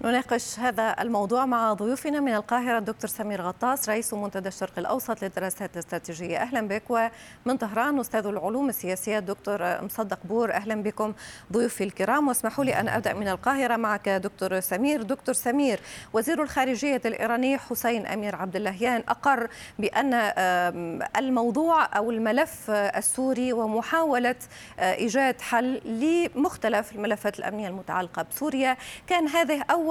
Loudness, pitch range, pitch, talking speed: -26 LUFS, 205-255 Hz, 230 Hz, 130 wpm